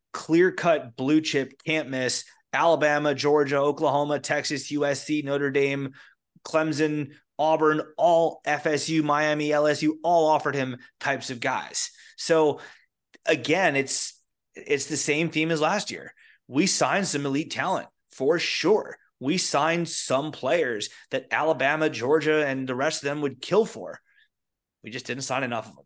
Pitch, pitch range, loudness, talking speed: 150 Hz, 140-160 Hz, -24 LUFS, 150 wpm